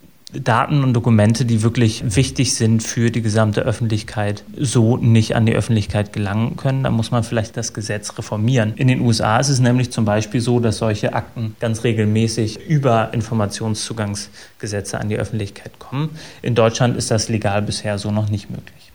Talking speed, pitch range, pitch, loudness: 175 wpm, 110-120 Hz, 115 Hz, -18 LUFS